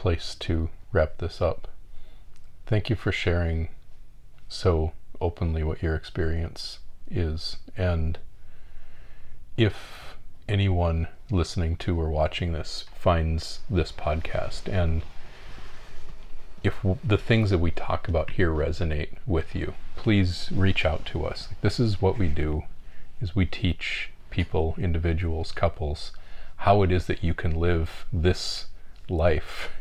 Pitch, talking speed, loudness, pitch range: 85 Hz, 130 wpm, -27 LUFS, 80-95 Hz